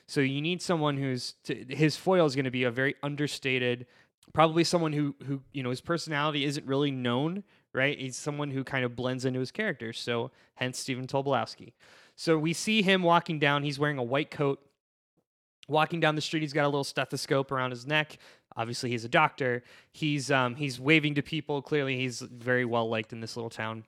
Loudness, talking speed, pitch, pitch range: -29 LUFS, 205 wpm, 140 Hz, 125-155 Hz